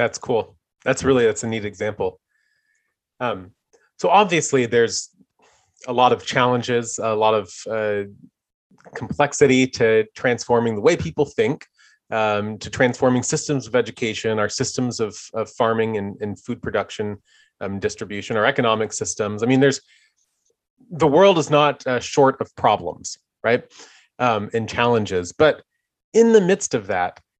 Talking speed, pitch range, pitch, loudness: 150 wpm, 110-145 Hz, 120 Hz, -20 LUFS